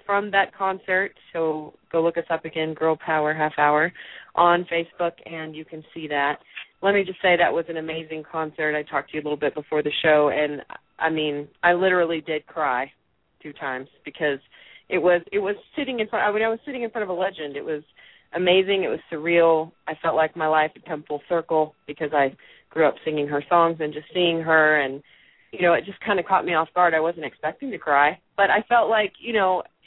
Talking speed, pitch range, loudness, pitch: 230 wpm, 150-180 Hz, -23 LUFS, 160 Hz